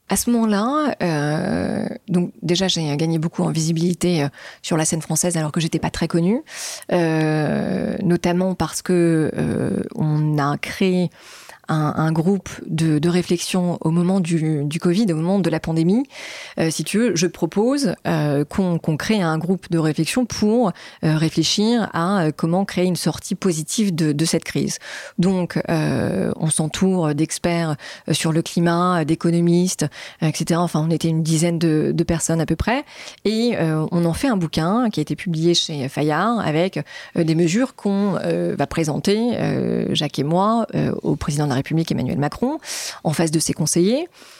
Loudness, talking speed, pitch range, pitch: -20 LUFS, 180 wpm, 160-195 Hz, 170 Hz